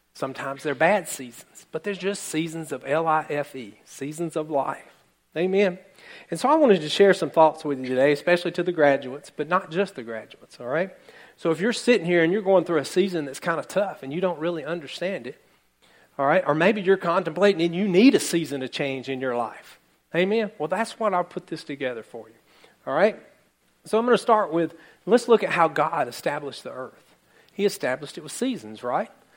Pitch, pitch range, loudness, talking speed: 170 Hz, 145-195 Hz, -23 LUFS, 215 wpm